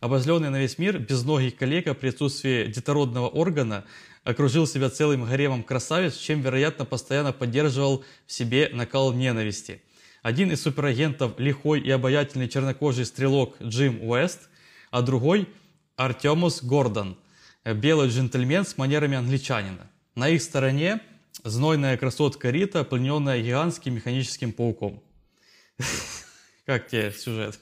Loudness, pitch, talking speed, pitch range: -25 LUFS, 135 Hz, 120 wpm, 125-150 Hz